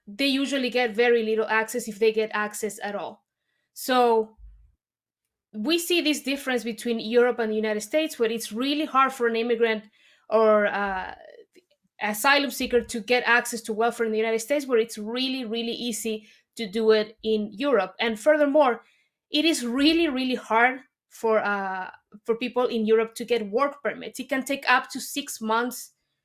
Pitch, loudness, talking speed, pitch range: 235 Hz, -24 LUFS, 175 wpm, 220-260 Hz